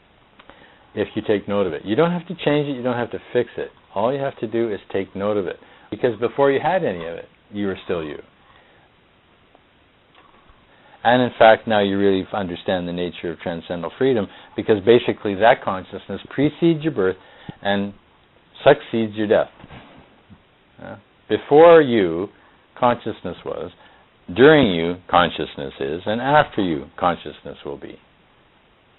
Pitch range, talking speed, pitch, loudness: 95-135 Hz, 155 wpm, 110 Hz, -20 LUFS